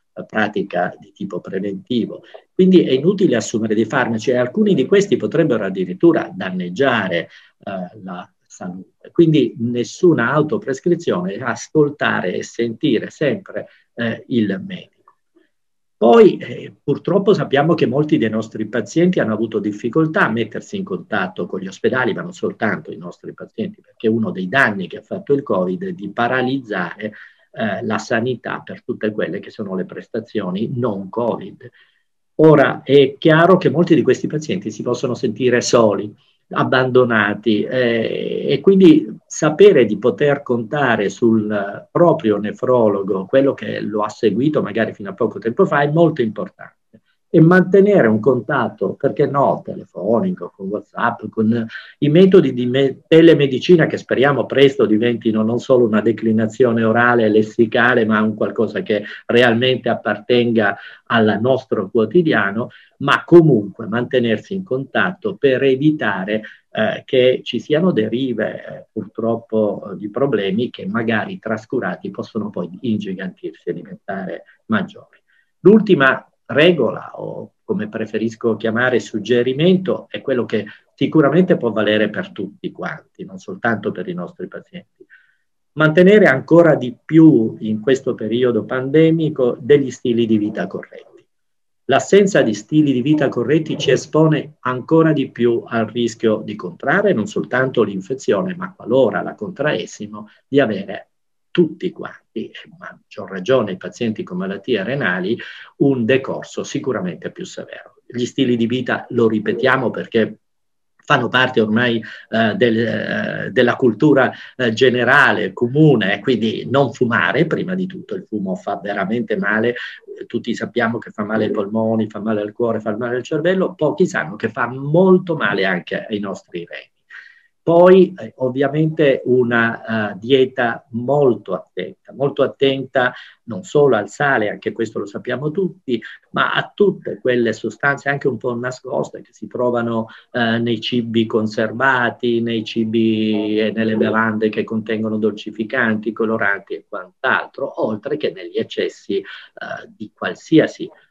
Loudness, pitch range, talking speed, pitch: -17 LUFS, 110-155 Hz, 140 wpm, 125 Hz